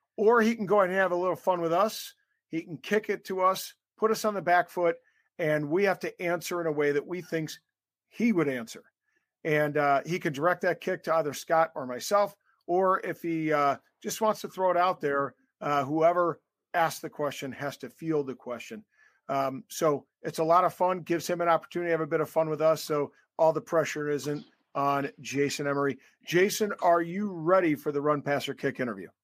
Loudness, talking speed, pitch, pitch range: -28 LUFS, 220 wpm, 165 Hz, 150-185 Hz